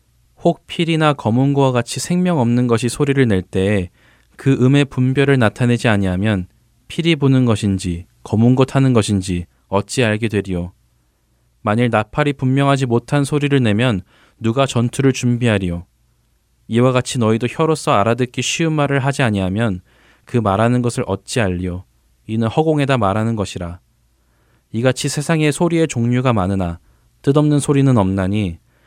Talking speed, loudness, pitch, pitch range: 320 characters per minute, -17 LUFS, 120 Hz, 100-135 Hz